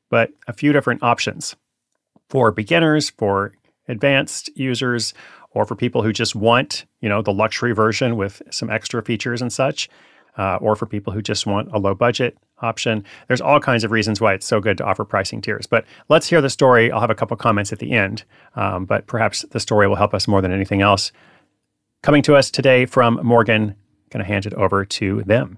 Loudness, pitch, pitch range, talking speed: -18 LUFS, 115 Hz, 105-125 Hz, 205 wpm